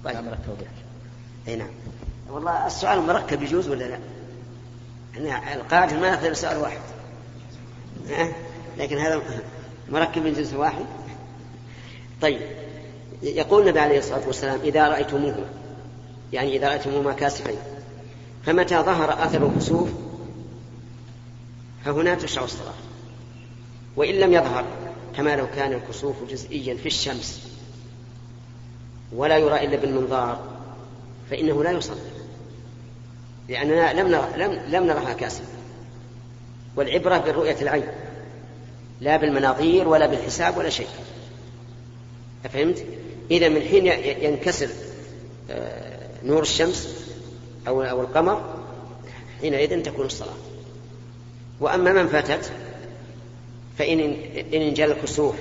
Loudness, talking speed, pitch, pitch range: -23 LUFS, 100 wpm, 125 Hz, 120-150 Hz